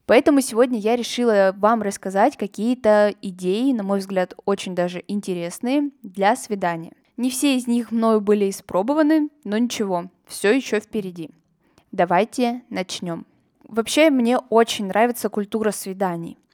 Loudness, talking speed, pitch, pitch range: -21 LUFS, 130 wpm, 215 Hz, 195-240 Hz